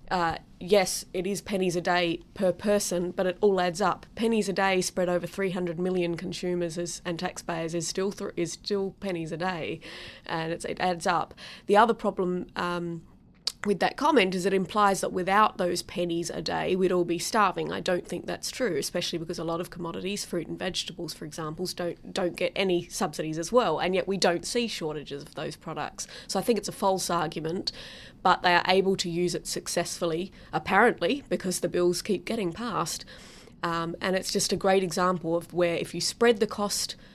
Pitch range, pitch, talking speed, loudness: 170-195 Hz, 180 Hz, 205 wpm, -28 LUFS